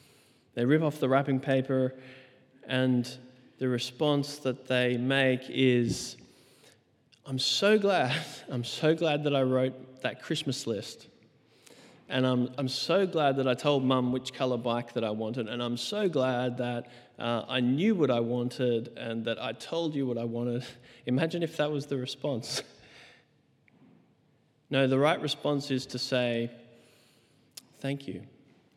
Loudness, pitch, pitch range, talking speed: -29 LUFS, 130 Hz, 120-140 Hz, 155 wpm